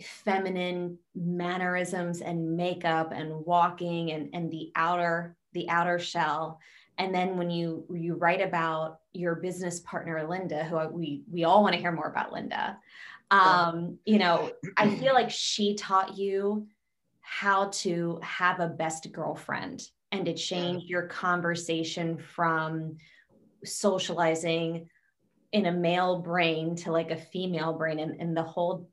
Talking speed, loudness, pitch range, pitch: 145 wpm, -29 LUFS, 165-180 Hz, 175 Hz